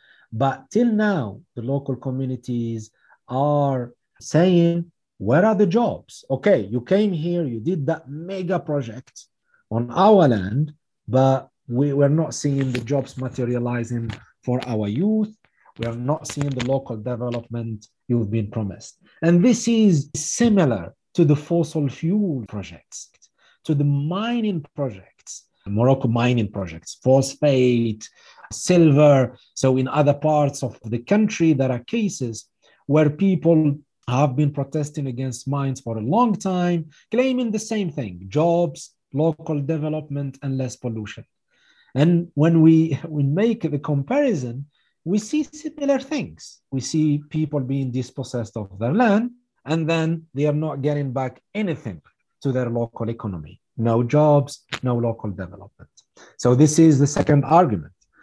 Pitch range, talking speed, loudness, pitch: 125-165 Hz, 140 wpm, -21 LUFS, 140 Hz